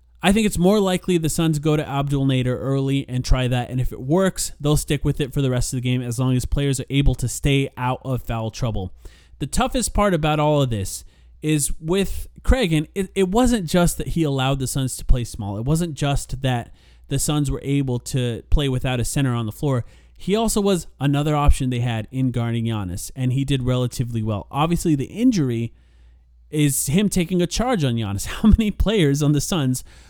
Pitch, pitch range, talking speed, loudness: 135 Hz, 120-155 Hz, 220 wpm, -21 LUFS